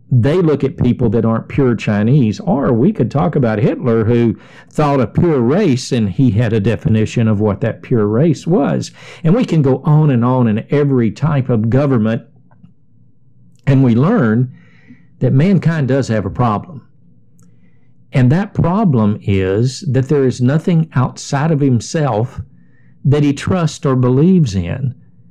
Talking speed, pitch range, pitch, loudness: 160 wpm, 115-145 Hz, 130 Hz, -14 LUFS